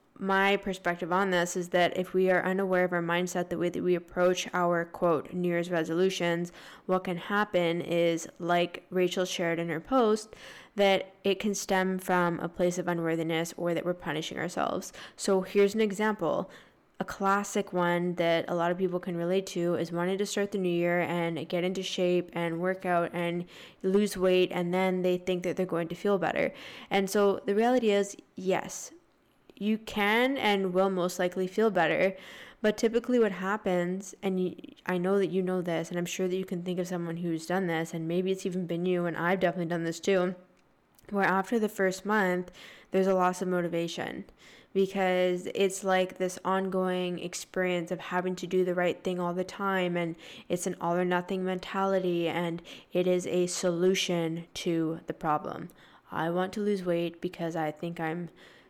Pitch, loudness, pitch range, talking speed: 180 Hz, -29 LUFS, 175-190 Hz, 195 wpm